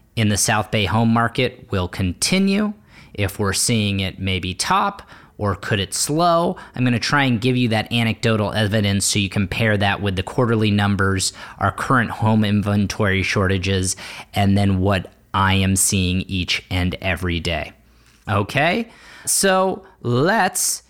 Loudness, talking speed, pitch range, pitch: -19 LUFS, 150 wpm, 95-120 Hz, 105 Hz